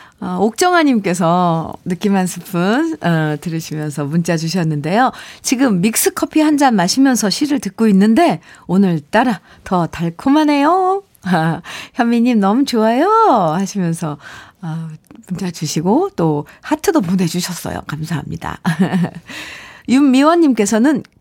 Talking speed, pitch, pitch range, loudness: 270 characters per minute, 190 Hz, 170-260 Hz, -15 LUFS